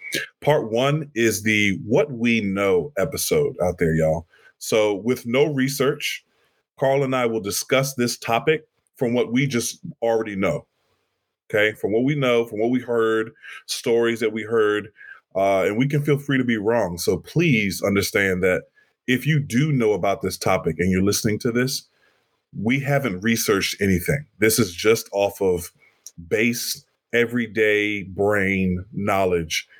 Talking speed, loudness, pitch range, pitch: 160 wpm, -21 LUFS, 105-130 Hz, 115 Hz